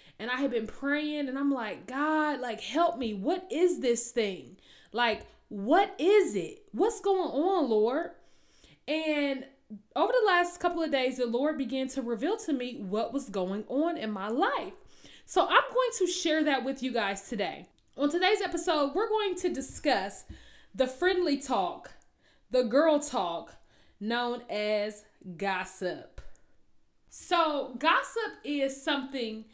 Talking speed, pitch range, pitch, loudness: 150 wpm, 235-340 Hz, 275 Hz, -29 LUFS